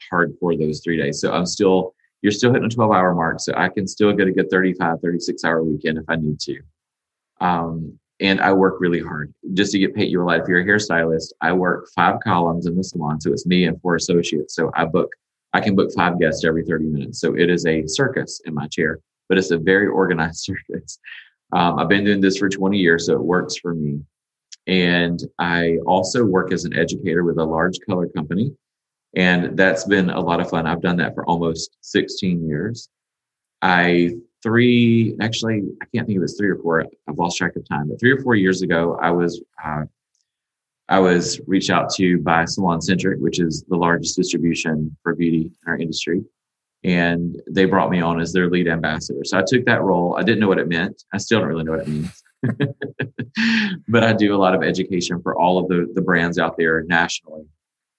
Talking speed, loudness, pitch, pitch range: 215 wpm, -19 LUFS, 90 Hz, 80-95 Hz